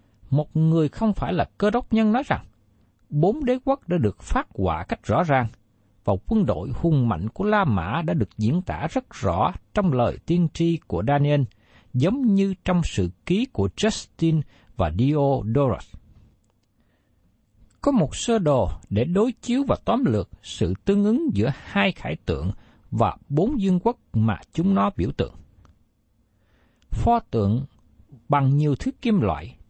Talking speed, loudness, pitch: 165 wpm, -23 LUFS, 130 Hz